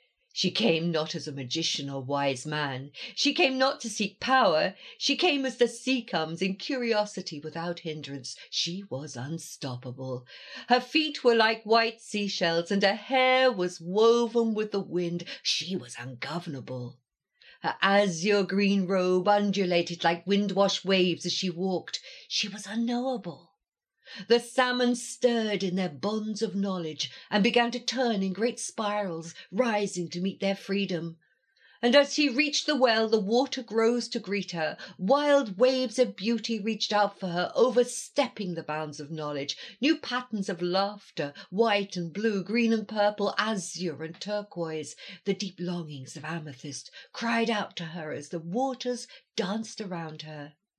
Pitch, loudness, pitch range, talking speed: 200 Hz, -28 LUFS, 170-235 Hz, 155 wpm